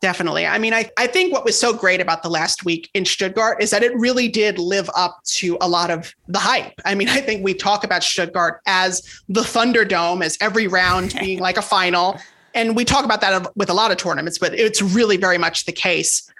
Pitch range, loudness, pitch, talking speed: 180-220 Hz, -18 LUFS, 195 Hz, 235 wpm